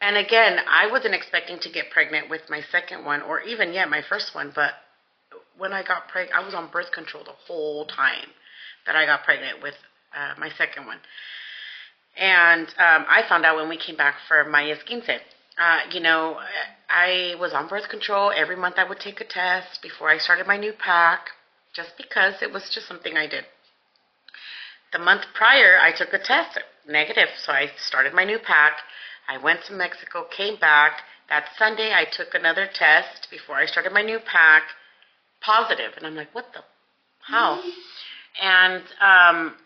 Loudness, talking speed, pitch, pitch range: -20 LUFS, 185 wpm, 180 Hz, 160-200 Hz